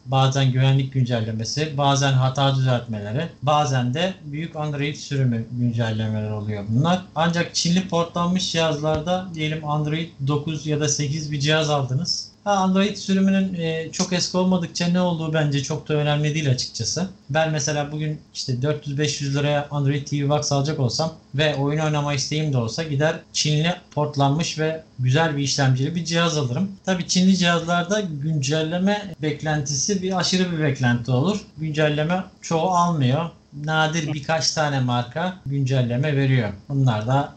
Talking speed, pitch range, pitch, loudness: 140 wpm, 135-165 Hz, 150 Hz, -22 LUFS